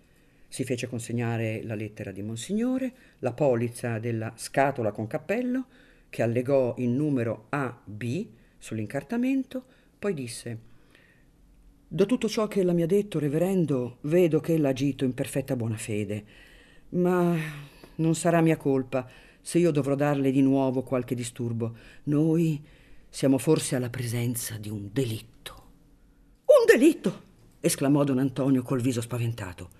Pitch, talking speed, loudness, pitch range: 135 Hz, 135 wpm, -27 LUFS, 120-165 Hz